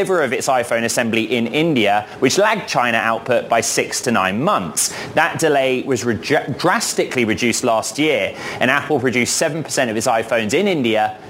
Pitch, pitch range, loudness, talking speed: 120 Hz, 115-150 Hz, -17 LUFS, 170 wpm